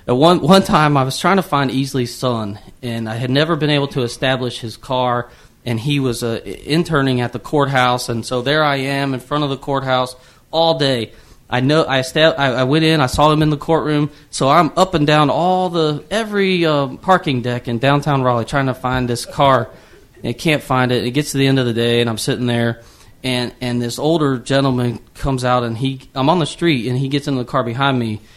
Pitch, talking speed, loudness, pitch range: 135 Hz, 235 wpm, -17 LUFS, 125-150 Hz